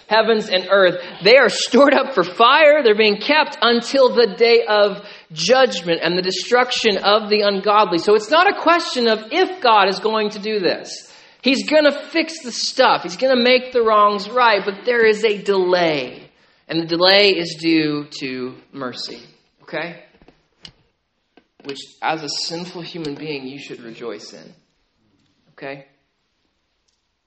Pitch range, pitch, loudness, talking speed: 175-250 Hz, 210 Hz, -16 LUFS, 160 wpm